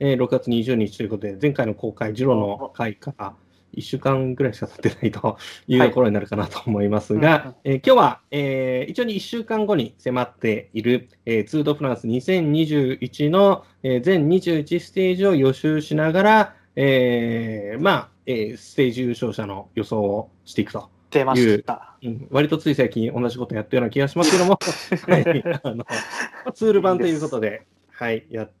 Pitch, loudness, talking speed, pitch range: 130 Hz, -21 LUFS, 290 characters per minute, 110-155 Hz